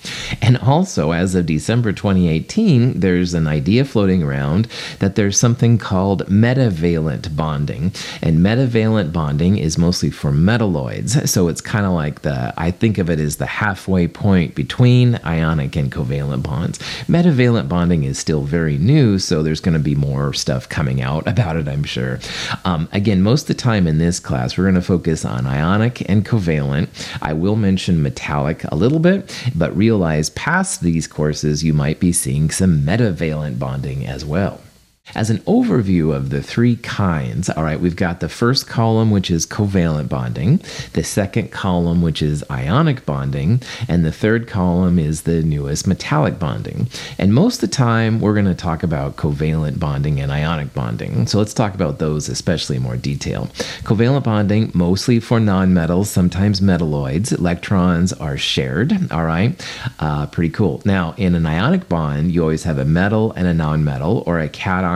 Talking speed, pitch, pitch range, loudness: 175 wpm, 90 Hz, 80-110 Hz, -17 LUFS